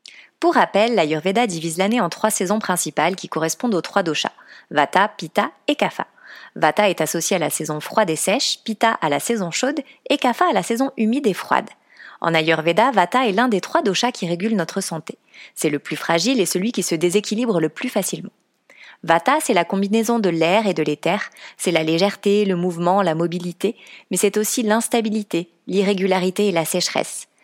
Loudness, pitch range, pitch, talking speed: -20 LUFS, 170-225 Hz, 195 Hz, 190 wpm